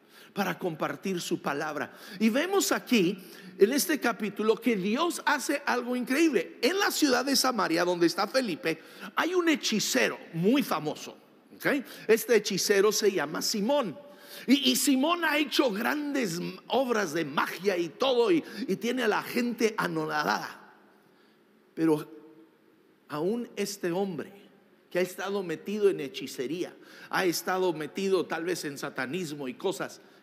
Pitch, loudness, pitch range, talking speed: 205 Hz, -28 LUFS, 180-265 Hz, 140 wpm